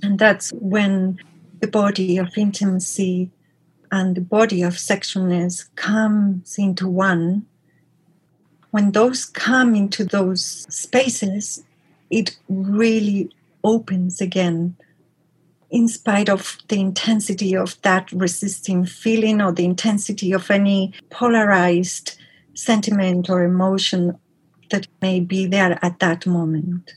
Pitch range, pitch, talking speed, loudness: 175-205 Hz, 190 Hz, 110 wpm, -19 LUFS